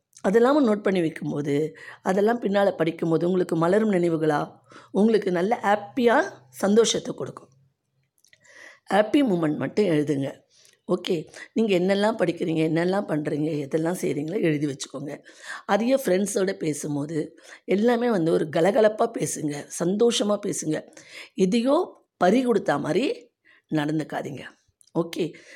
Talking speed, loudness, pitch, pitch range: 105 wpm, -24 LUFS, 180 Hz, 155-215 Hz